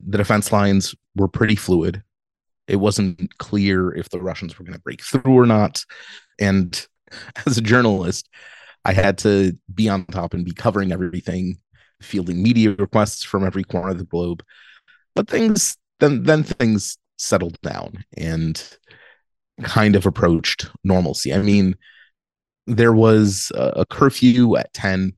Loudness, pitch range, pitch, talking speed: -19 LUFS, 90-110 Hz, 100 Hz, 150 wpm